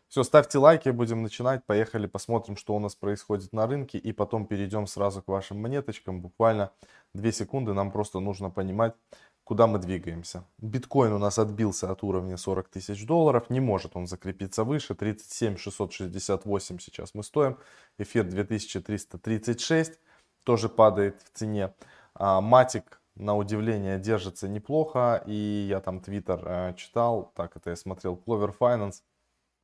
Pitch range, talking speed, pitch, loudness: 95-115 Hz, 145 wpm, 105 Hz, -28 LUFS